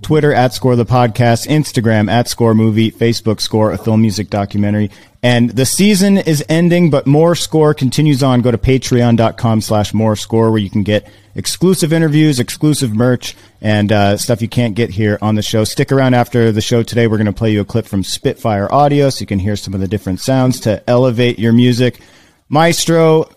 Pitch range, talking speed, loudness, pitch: 105-135 Hz, 205 wpm, -13 LUFS, 115 Hz